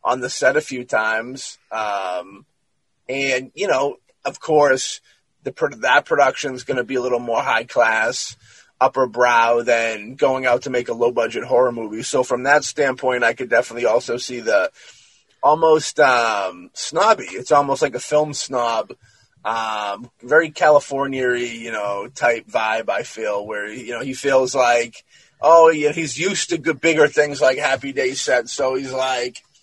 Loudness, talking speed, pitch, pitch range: -19 LUFS, 175 wpm, 135 Hz, 120-155 Hz